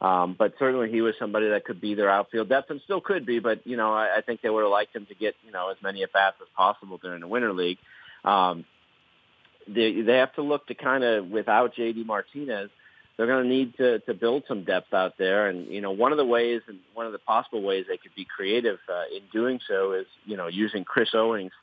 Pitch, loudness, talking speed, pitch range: 115 Hz, -26 LUFS, 245 wpm, 100-125 Hz